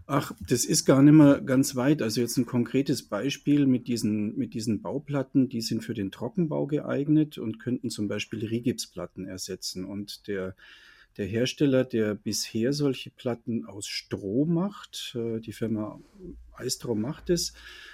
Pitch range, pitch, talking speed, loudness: 110-140 Hz, 120 Hz, 155 wpm, -27 LUFS